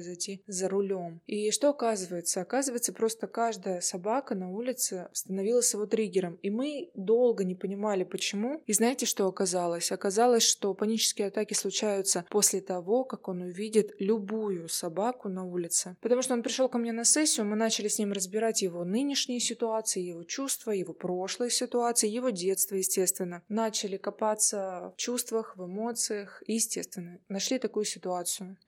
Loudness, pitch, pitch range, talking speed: -29 LUFS, 210 Hz, 190-230 Hz, 155 wpm